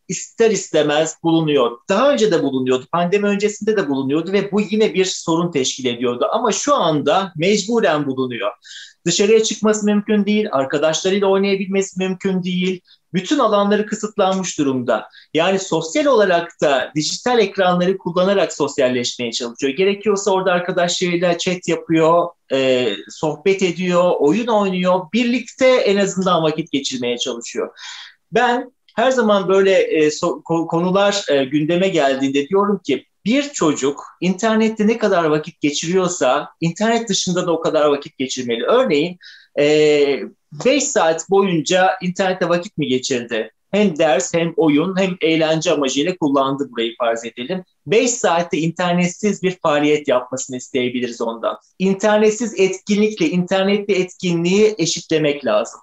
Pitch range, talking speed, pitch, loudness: 150-200 Hz, 125 wpm, 180 Hz, -17 LUFS